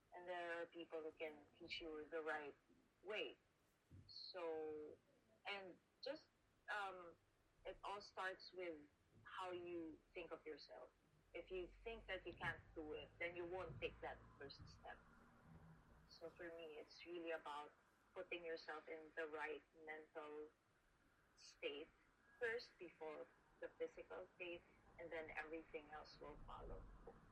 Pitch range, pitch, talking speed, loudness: 155-180 Hz, 165 Hz, 140 wpm, -54 LUFS